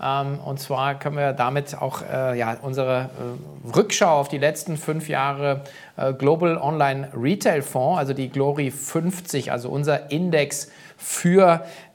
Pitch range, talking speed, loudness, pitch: 135-155 Hz, 130 wpm, -22 LUFS, 140 Hz